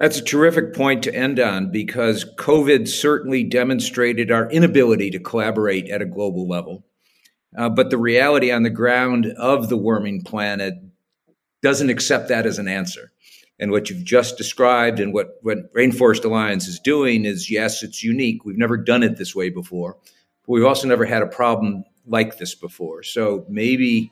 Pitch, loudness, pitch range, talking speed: 120 Hz, -19 LUFS, 105-130 Hz, 175 wpm